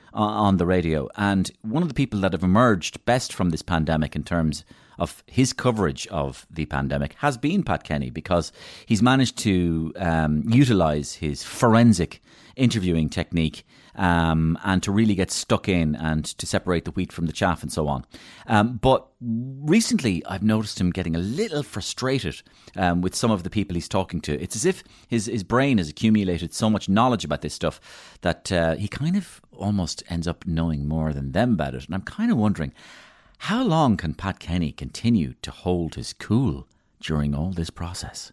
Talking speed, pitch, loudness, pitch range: 190 wpm, 90 Hz, -23 LUFS, 80-110 Hz